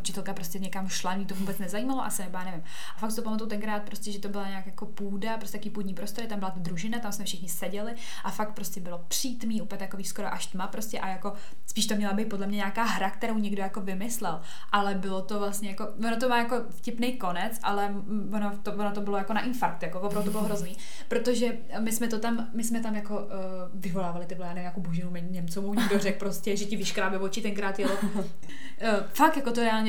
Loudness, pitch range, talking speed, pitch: -31 LUFS, 195-220 Hz, 230 wpm, 205 Hz